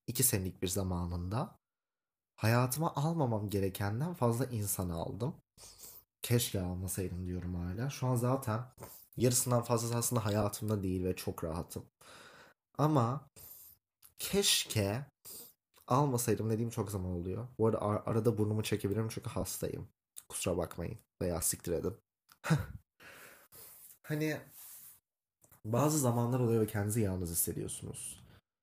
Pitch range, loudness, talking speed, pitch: 95-125 Hz, -34 LUFS, 110 wpm, 110 Hz